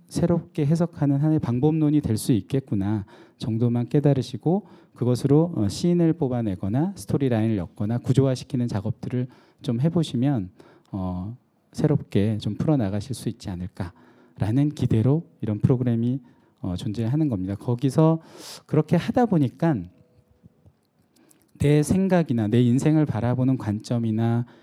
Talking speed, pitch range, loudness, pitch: 310 characters per minute, 110-150 Hz, -24 LUFS, 125 Hz